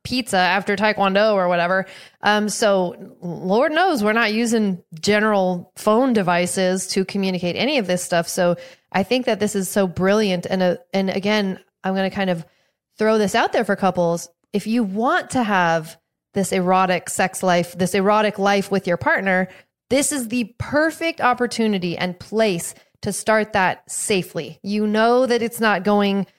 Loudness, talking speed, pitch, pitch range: -20 LUFS, 175 wpm, 195 Hz, 180-220 Hz